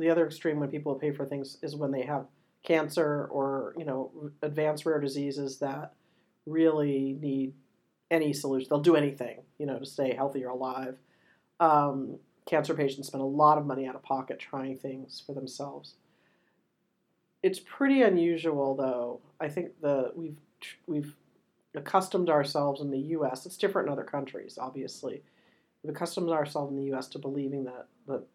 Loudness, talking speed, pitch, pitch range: -30 LUFS, 170 wpm, 145 Hz, 135-155 Hz